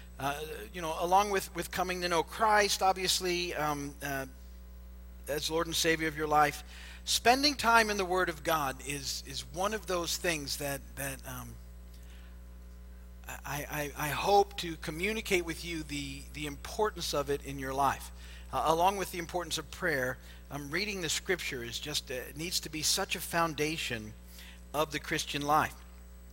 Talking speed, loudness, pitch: 170 wpm, -32 LUFS, 150 Hz